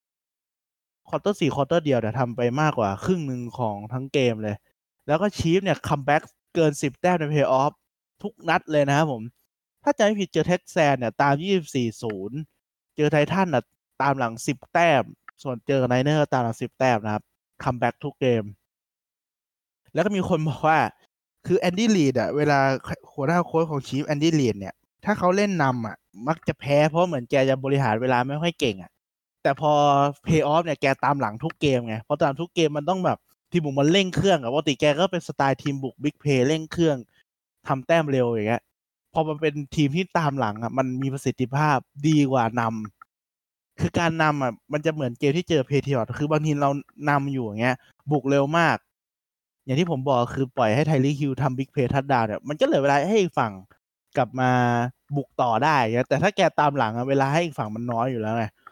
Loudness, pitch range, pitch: -23 LUFS, 125-155 Hz, 140 Hz